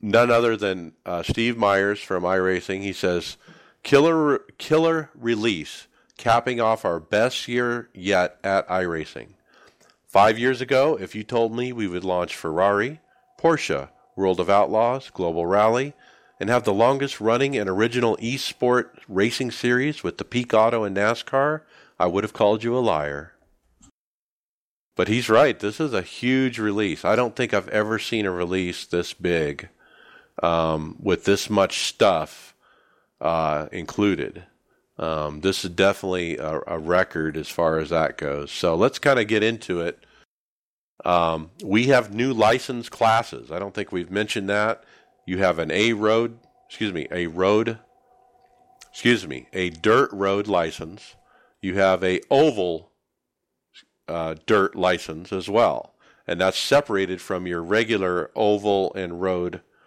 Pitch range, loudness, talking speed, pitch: 90-120 Hz, -22 LUFS, 150 wpm, 105 Hz